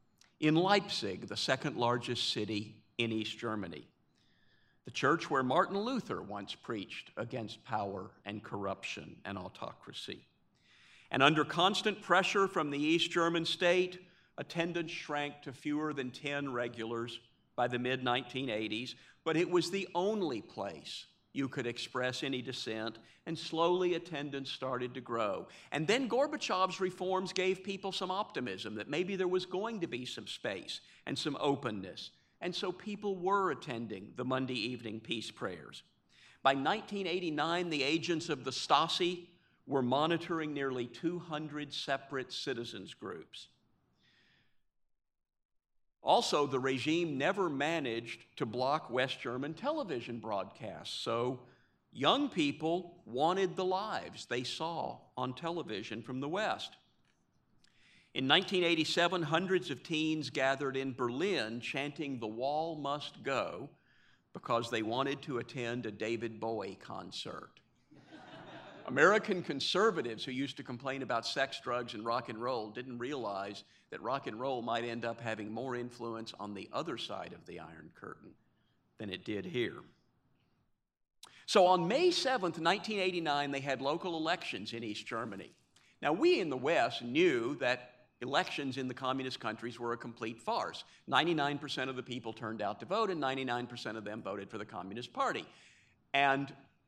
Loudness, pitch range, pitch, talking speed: -35 LUFS, 120-170 Hz, 135 Hz, 145 wpm